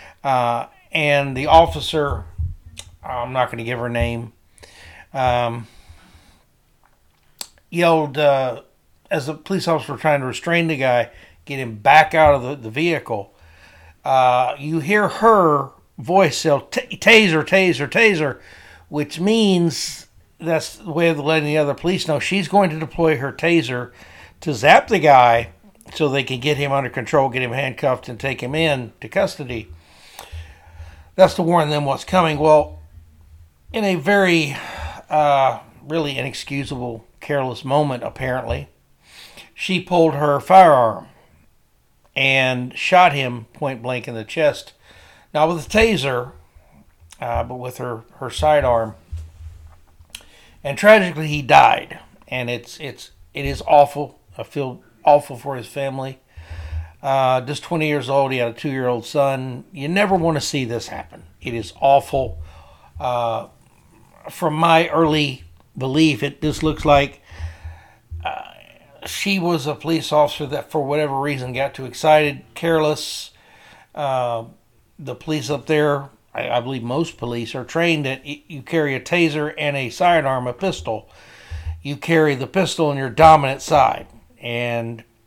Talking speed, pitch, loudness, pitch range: 145 wpm, 140 Hz, -18 LUFS, 120-155 Hz